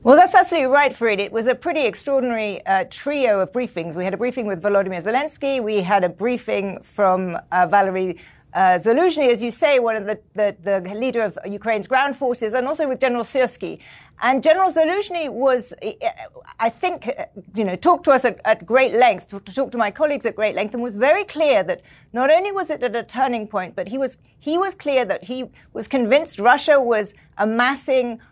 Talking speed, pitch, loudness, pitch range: 205 wpm, 245 Hz, -20 LUFS, 205-280 Hz